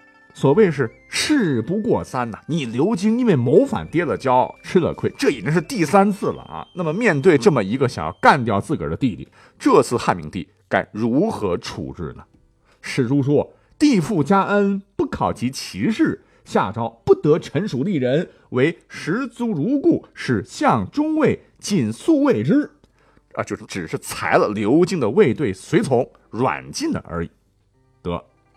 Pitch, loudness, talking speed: 205 Hz, -20 LUFS, 235 characters per minute